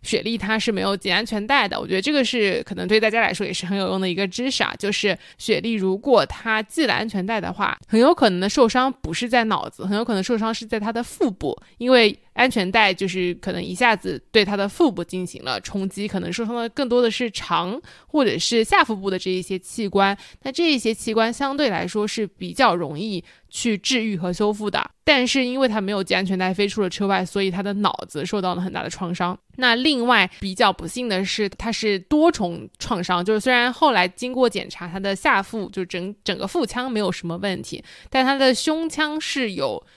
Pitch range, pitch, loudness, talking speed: 190-240 Hz, 215 Hz, -21 LUFS, 325 characters per minute